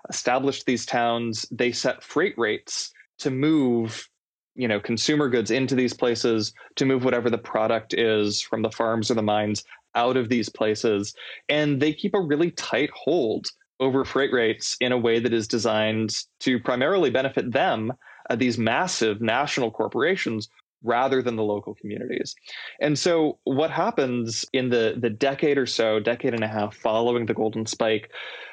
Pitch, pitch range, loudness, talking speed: 120 Hz, 110-130 Hz, -24 LUFS, 170 wpm